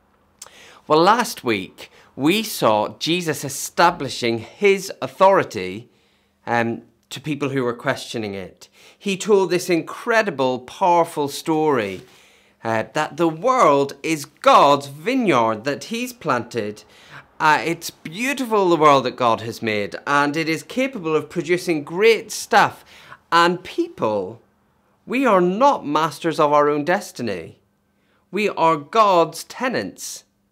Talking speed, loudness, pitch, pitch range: 125 wpm, -19 LUFS, 160 Hz, 135-195 Hz